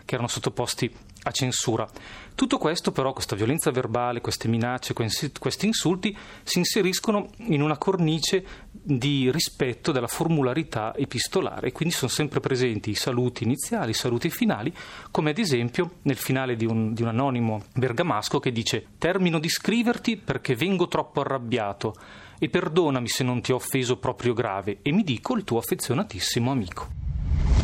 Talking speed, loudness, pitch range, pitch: 160 wpm, -26 LUFS, 120-165 Hz, 130 Hz